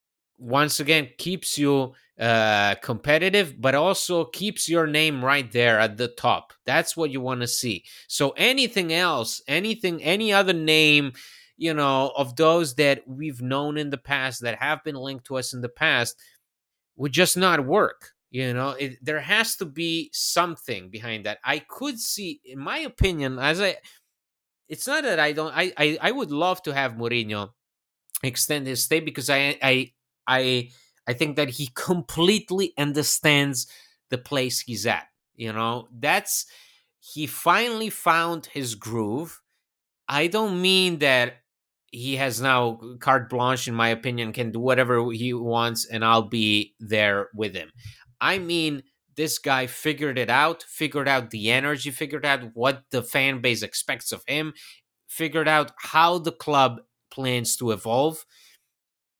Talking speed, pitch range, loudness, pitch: 160 wpm, 120-160 Hz, -23 LUFS, 140 Hz